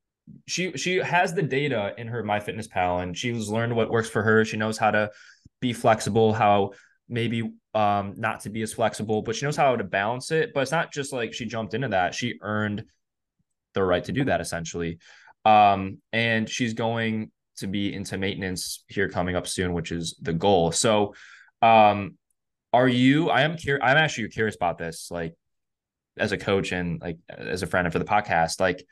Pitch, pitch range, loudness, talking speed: 110 Hz, 95-115 Hz, -24 LUFS, 200 wpm